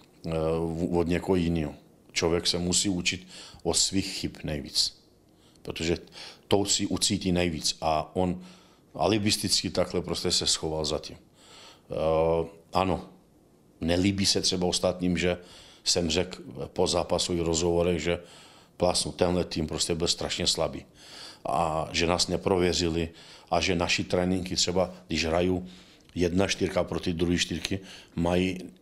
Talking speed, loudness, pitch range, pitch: 130 wpm, -27 LUFS, 85-90 Hz, 90 Hz